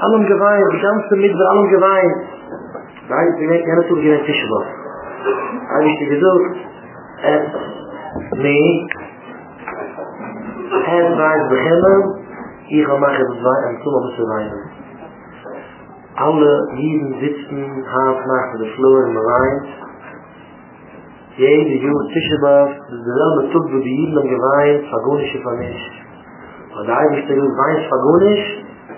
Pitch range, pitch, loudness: 135-170 Hz, 145 Hz, -15 LUFS